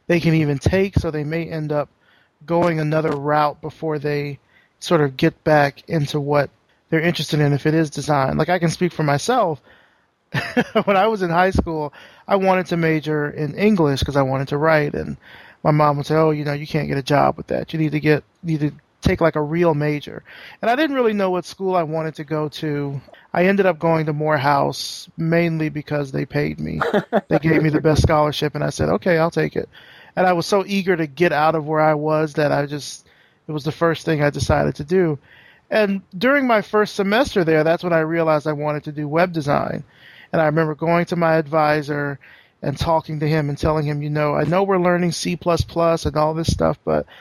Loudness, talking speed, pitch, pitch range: -19 LUFS, 230 wpm, 155 Hz, 150-170 Hz